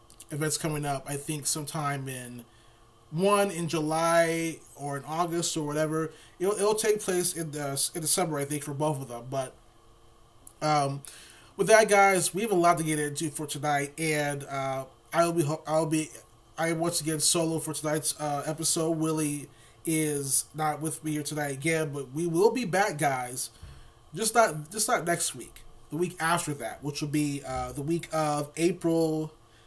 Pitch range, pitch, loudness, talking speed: 135-165 Hz, 155 Hz, -28 LUFS, 180 wpm